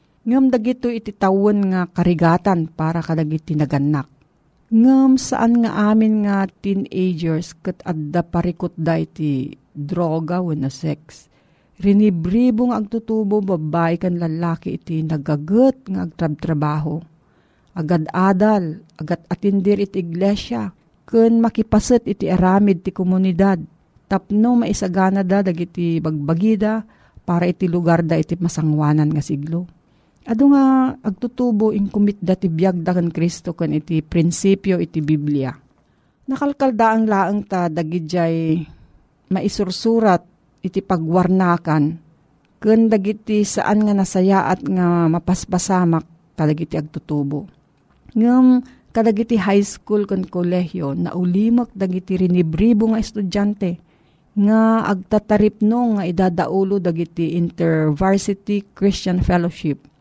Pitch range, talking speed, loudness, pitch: 165-210 Hz, 110 wpm, -18 LUFS, 185 Hz